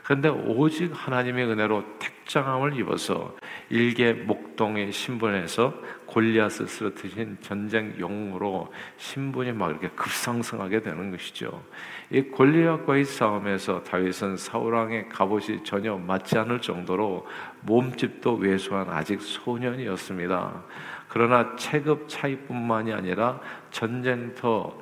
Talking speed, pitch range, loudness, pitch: 285 characters per minute, 100-125 Hz, -26 LUFS, 115 Hz